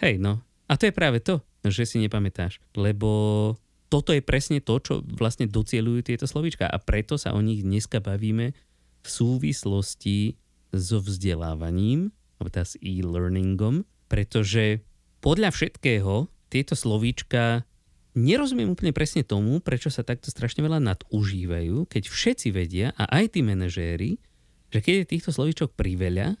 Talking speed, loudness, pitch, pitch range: 145 wpm, -25 LUFS, 110 Hz, 95-140 Hz